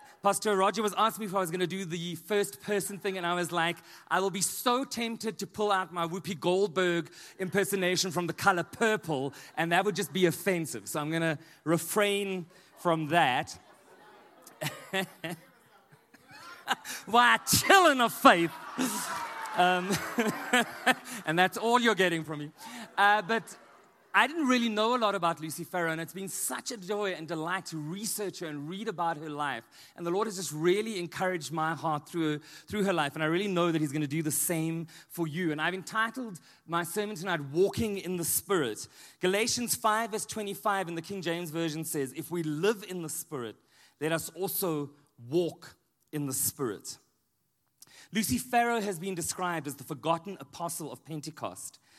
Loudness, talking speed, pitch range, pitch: -30 LUFS, 180 wpm, 165-205 Hz, 180 Hz